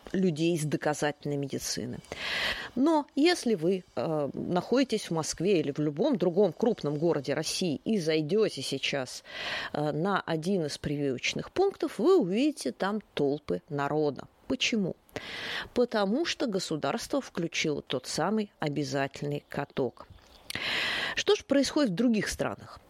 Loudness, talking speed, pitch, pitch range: -29 LUFS, 125 wpm, 175 Hz, 150-230 Hz